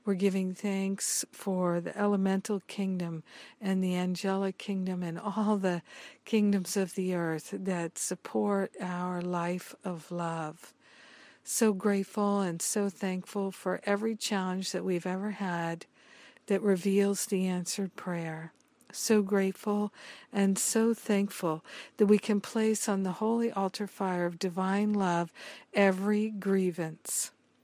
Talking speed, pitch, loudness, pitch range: 130 wpm, 195 Hz, -31 LUFS, 180-205 Hz